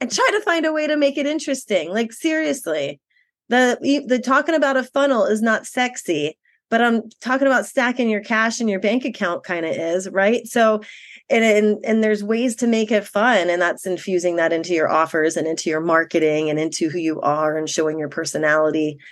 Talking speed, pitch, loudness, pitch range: 205 wpm, 215 Hz, -19 LUFS, 165-255 Hz